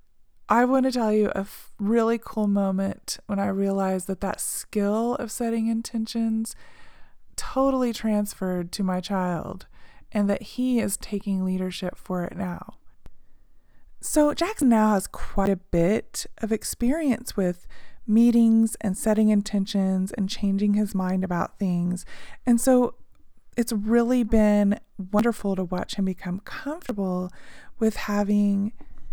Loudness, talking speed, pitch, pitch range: -25 LUFS, 135 wpm, 205 Hz, 190-230 Hz